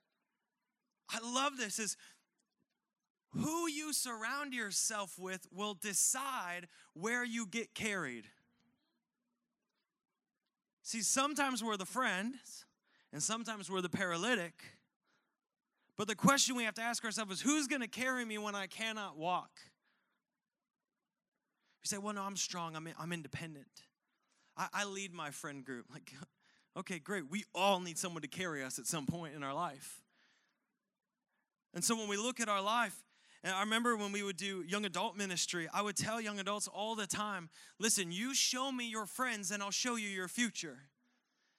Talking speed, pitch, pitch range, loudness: 165 wpm, 210 Hz, 185-240 Hz, -37 LUFS